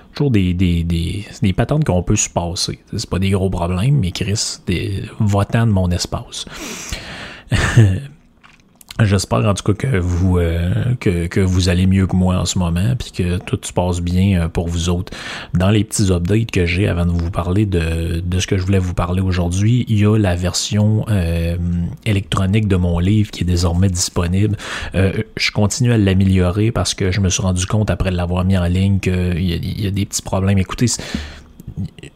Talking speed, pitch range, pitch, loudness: 200 wpm, 90-105 Hz, 95 Hz, -17 LUFS